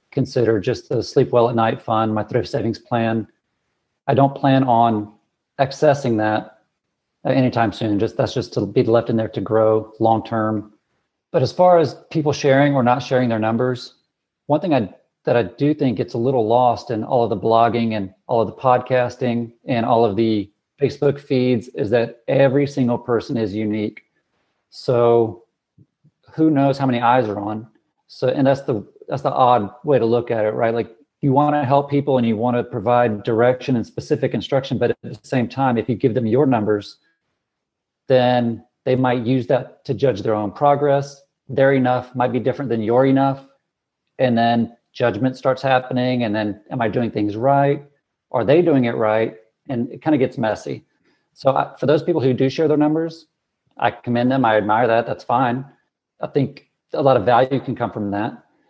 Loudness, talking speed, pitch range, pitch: -19 LUFS, 195 wpm, 115-135 Hz, 125 Hz